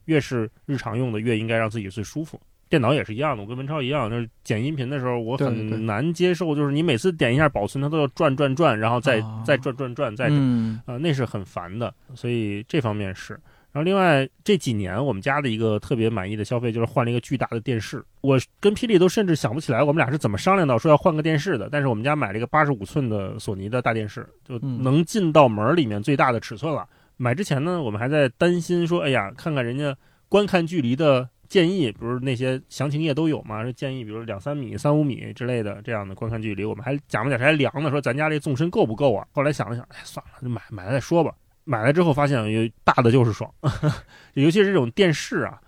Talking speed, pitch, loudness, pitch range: 370 characters per minute, 135 Hz, -23 LUFS, 115-150 Hz